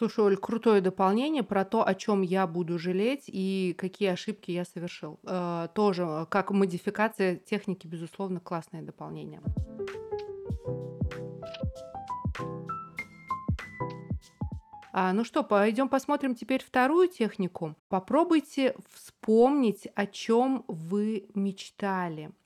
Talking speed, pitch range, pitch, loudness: 100 wpm, 180-235 Hz, 195 Hz, -29 LUFS